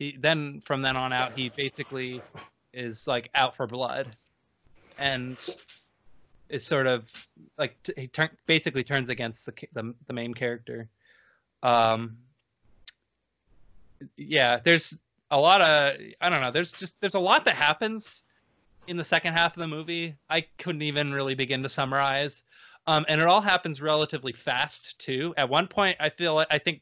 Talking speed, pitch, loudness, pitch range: 170 wpm, 140 Hz, -26 LUFS, 125-160 Hz